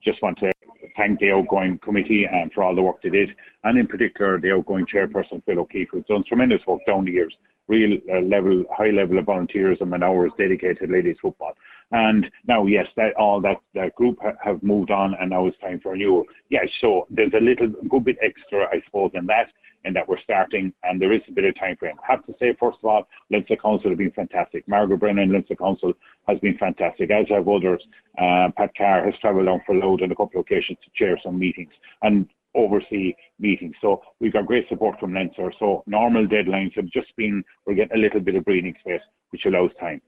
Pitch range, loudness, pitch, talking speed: 95-110 Hz, -21 LUFS, 100 Hz, 230 wpm